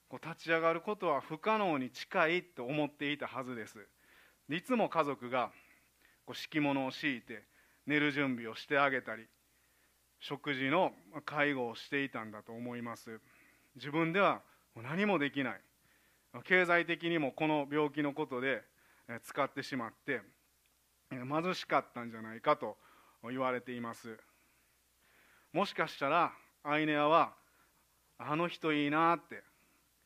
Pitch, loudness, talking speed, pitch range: 140 Hz, -34 LUFS, 265 characters per minute, 115-155 Hz